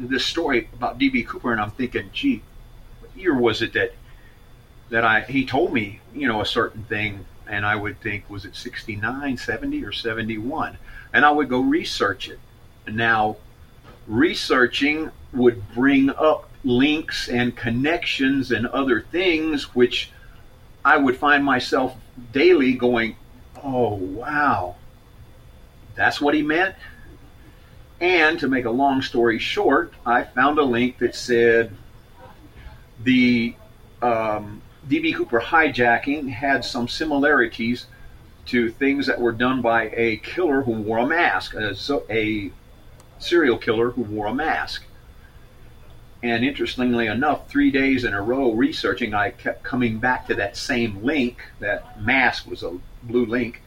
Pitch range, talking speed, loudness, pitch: 115-135 Hz, 145 wpm, -21 LUFS, 120 Hz